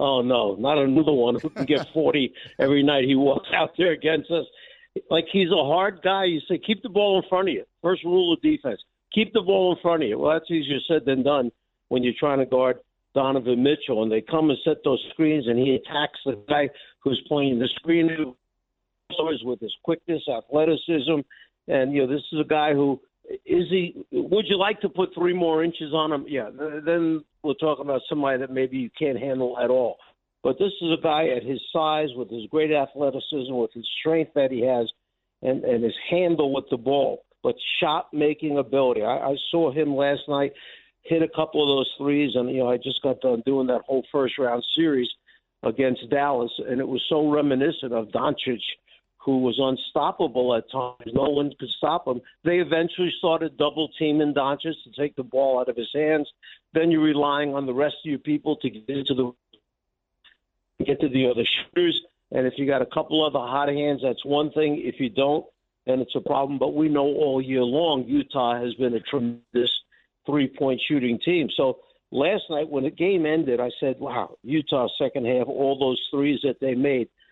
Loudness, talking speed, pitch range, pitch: -24 LUFS, 205 wpm, 130-160 Hz, 145 Hz